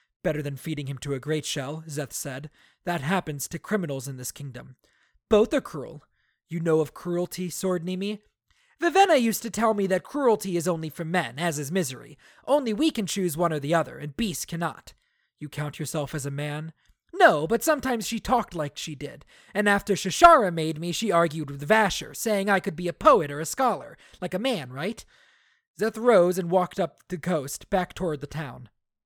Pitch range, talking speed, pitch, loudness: 150-210 Hz, 200 wpm, 175 Hz, -25 LUFS